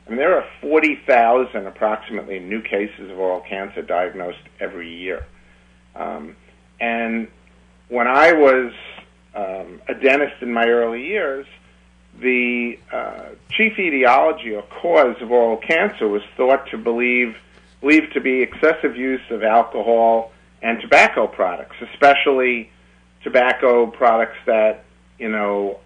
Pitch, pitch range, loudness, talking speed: 115 Hz, 90-125 Hz, -18 LUFS, 130 wpm